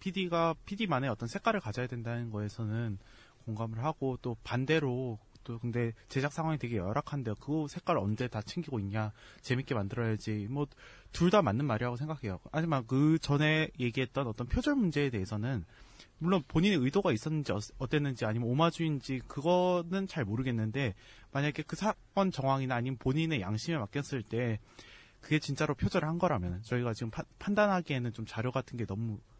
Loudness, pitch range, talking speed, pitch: -33 LUFS, 115-155 Hz, 385 characters per minute, 130 Hz